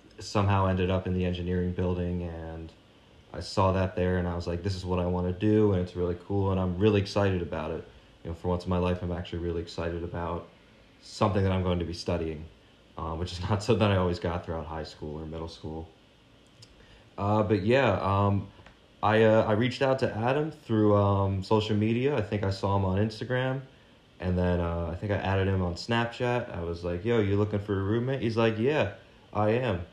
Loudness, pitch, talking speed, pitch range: -28 LUFS, 95 Hz, 225 wpm, 90-110 Hz